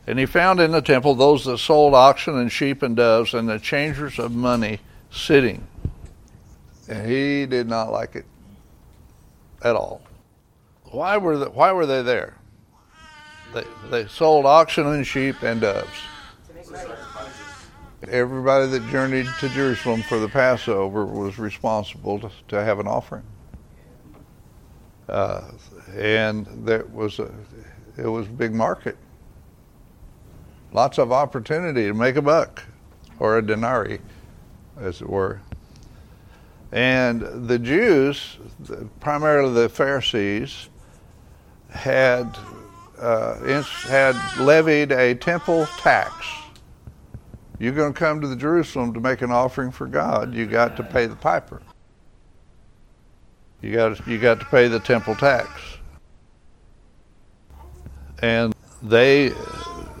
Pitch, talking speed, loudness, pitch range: 120 Hz, 125 wpm, -20 LUFS, 110-140 Hz